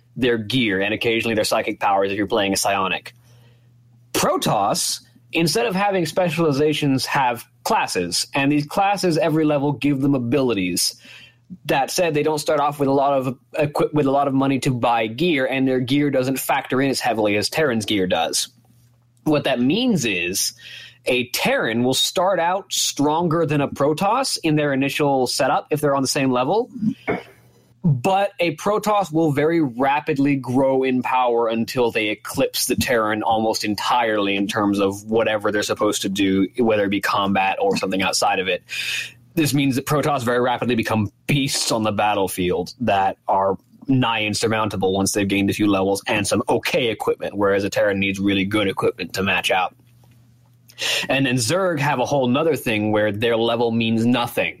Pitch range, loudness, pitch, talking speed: 110-145 Hz, -20 LUFS, 125 Hz, 175 wpm